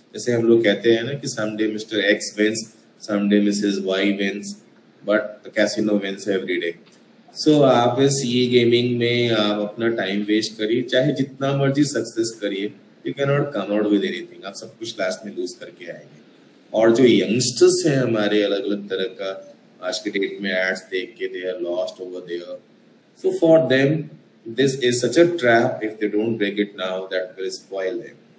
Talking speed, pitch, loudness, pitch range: 135 wpm, 110 Hz, -20 LUFS, 100-135 Hz